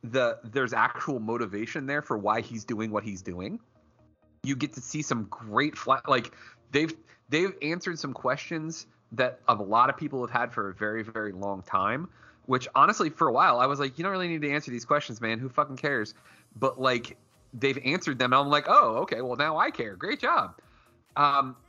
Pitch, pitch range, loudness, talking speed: 125 Hz, 110-145 Hz, -27 LUFS, 210 wpm